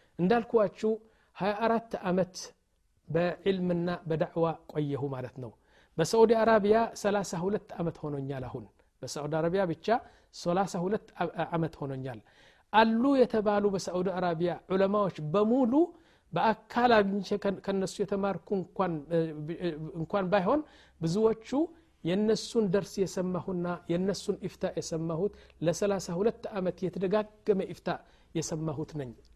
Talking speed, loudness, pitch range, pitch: 90 wpm, -30 LUFS, 165-210 Hz, 190 Hz